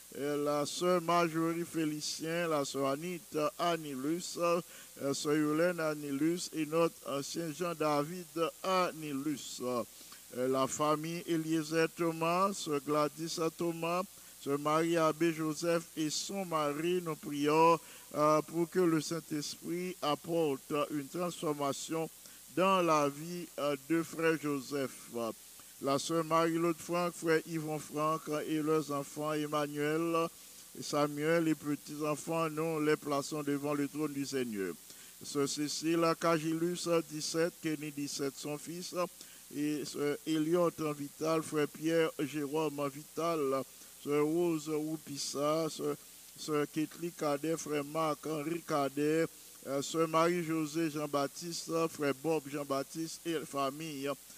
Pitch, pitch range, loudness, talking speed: 155 Hz, 145-165 Hz, -34 LUFS, 120 wpm